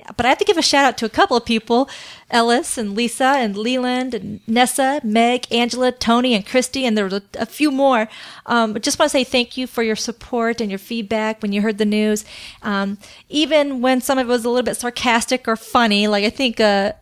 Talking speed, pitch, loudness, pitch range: 230 wpm, 235 Hz, -18 LUFS, 220-255 Hz